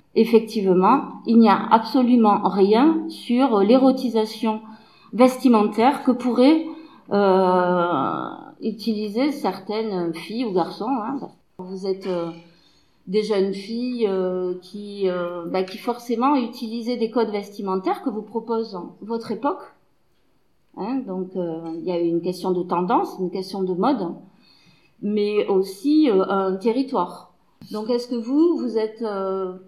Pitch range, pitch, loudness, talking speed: 190-245 Hz, 215 Hz, -21 LUFS, 130 wpm